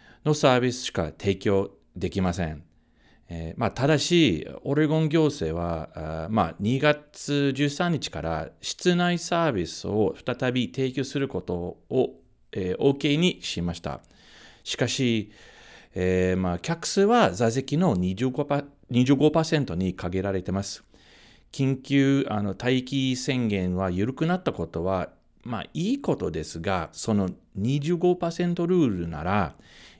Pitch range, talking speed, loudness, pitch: 90-145 Hz, 230 characters per minute, -25 LUFS, 120 Hz